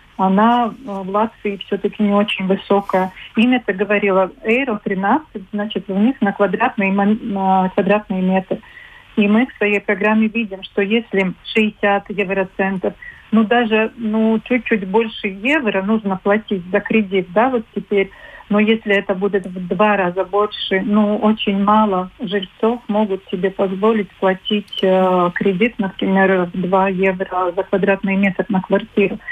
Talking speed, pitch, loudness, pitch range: 140 wpm, 205 Hz, -17 LUFS, 195-220 Hz